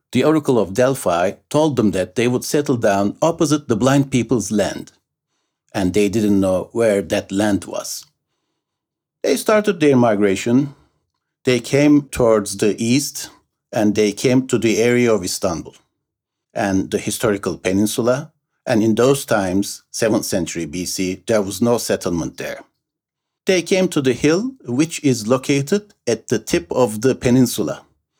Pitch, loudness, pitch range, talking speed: 120 Hz, -18 LUFS, 105-140 Hz, 150 wpm